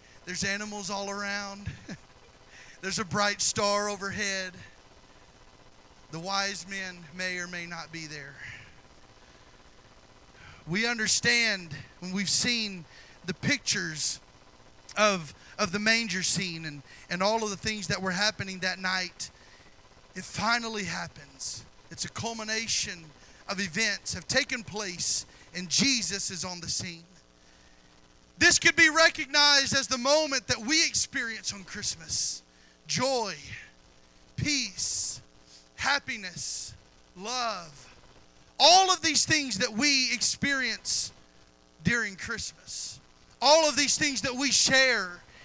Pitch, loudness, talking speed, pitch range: 190 Hz, -26 LUFS, 120 wpm, 135-225 Hz